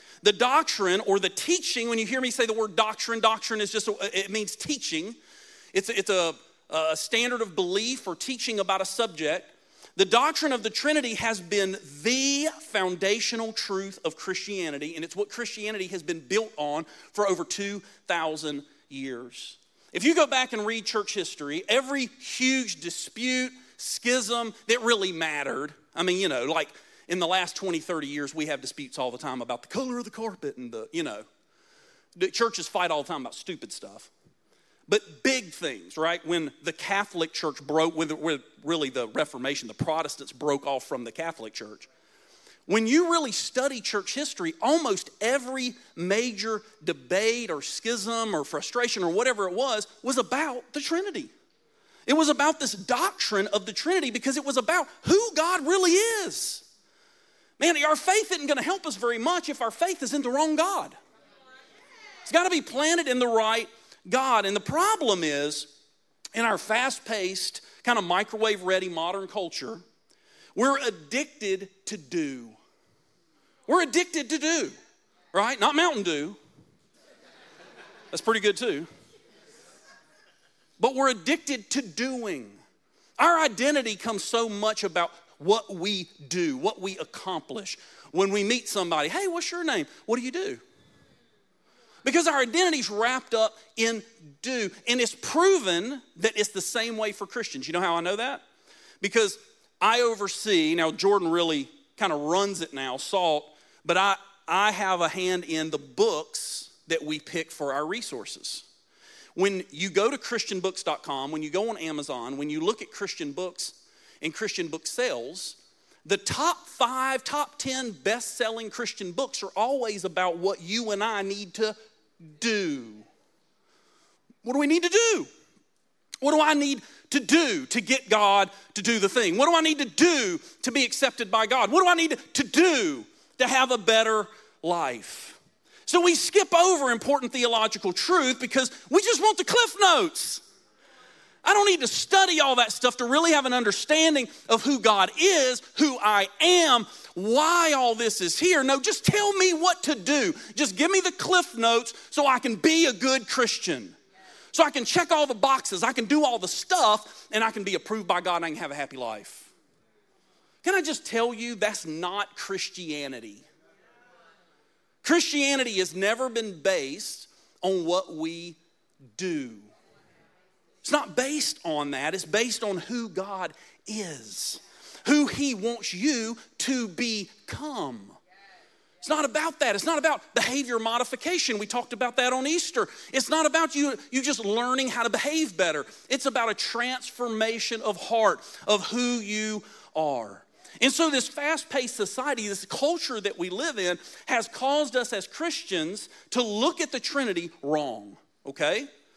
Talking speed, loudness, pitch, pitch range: 170 wpm, -26 LUFS, 235 Hz, 195-295 Hz